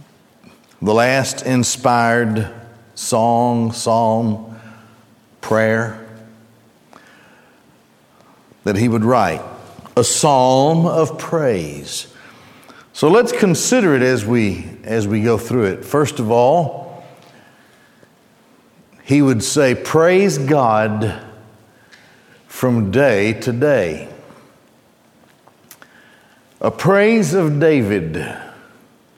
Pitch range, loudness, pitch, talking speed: 110-140 Hz, -16 LUFS, 120 Hz, 85 wpm